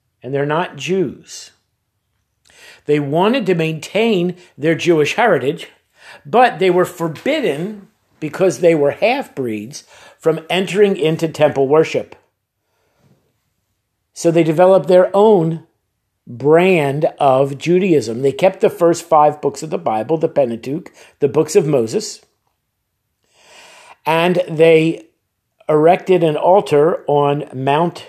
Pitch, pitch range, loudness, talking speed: 160 Hz, 140-180 Hz, -15 LUFS, 120 wpm